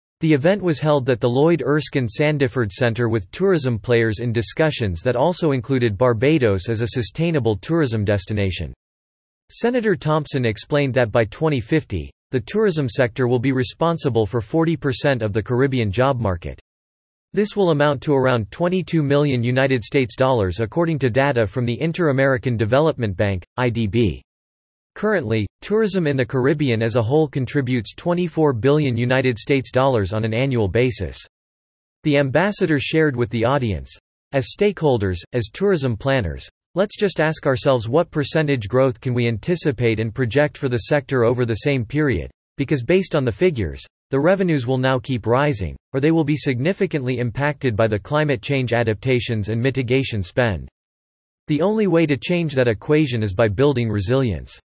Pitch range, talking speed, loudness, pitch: 115-150 Hz, 160 wpm, -20 LUFS, 130 Hz